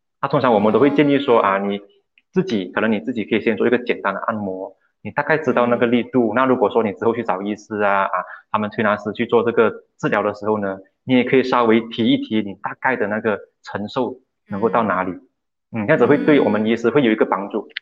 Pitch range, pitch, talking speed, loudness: 105-130 Hz, 115 Hz, 355 characters per minute, -19 LUFS